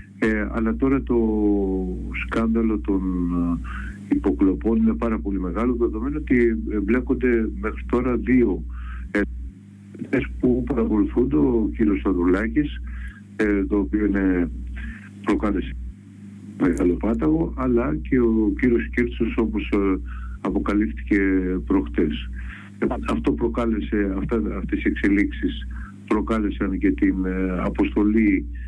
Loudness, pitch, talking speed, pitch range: -22 LUFS, 100 Hz, 105 wpm, 85-110 Hz